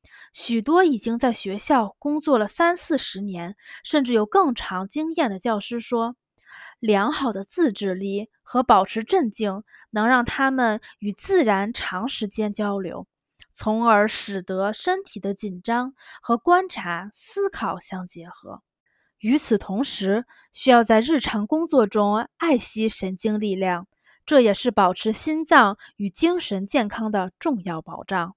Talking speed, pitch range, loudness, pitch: 210 characters per minute, 200-275 Hz, -22 LUFS, 220 Hz